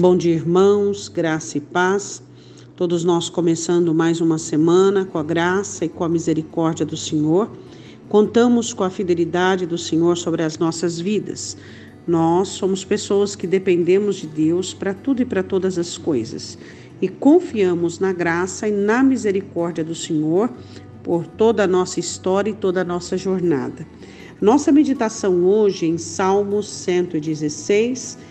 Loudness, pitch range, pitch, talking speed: -19 LUFS, 165-195 Hz, 180 Hz, 150 wpm